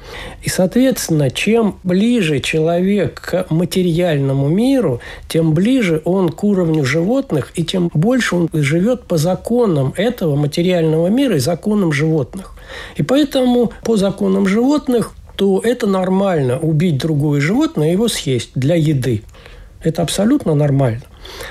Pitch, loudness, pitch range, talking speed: 175 Hz, -16 LUFS, 155-215 Hz, 130 wpm